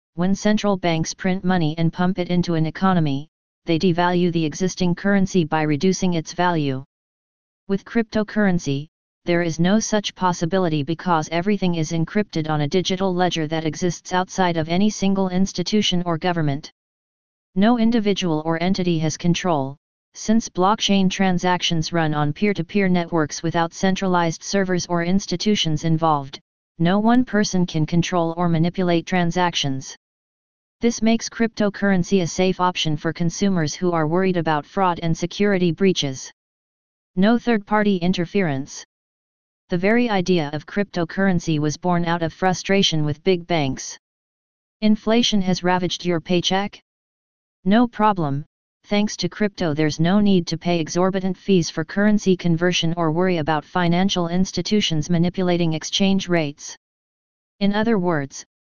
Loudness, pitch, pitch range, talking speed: -21 LUFS, 180 Hz, 165-195 Hz, 140 wpm